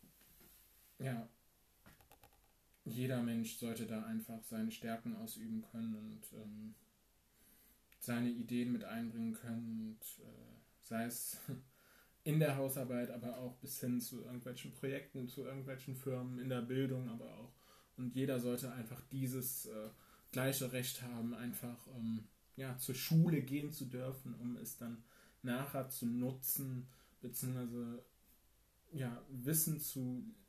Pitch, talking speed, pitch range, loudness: 125 Hz, 130 wpm, 120-135 Hz, -42 LUFS